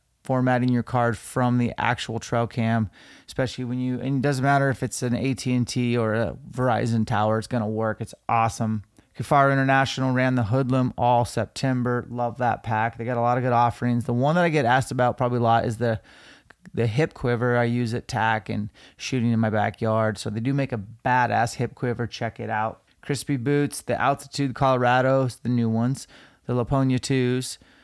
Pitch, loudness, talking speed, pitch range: 120 Hz, -24 LUFS, 200 wpm, 115-130 Hz